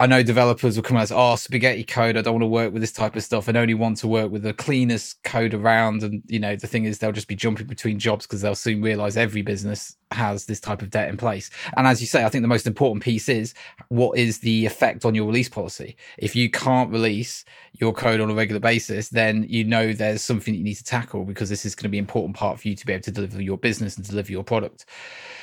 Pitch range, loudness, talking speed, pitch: 105-120 Hz, -22 LUFS, 270 wpm, 110 Hz